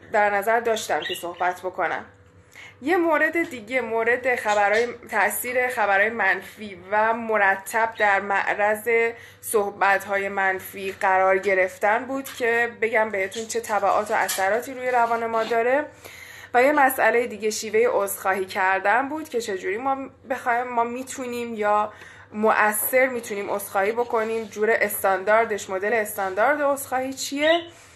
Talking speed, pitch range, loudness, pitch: 125 wpm, 200-250 Hz, -22 LUFS, 225 Hz